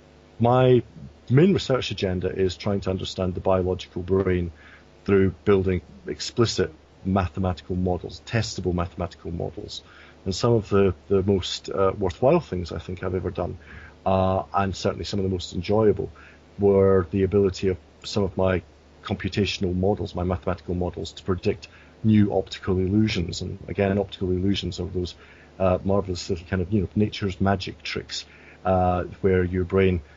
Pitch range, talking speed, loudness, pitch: 90-100 Hz, 155 wpm, -24 LUFS, 95 Hz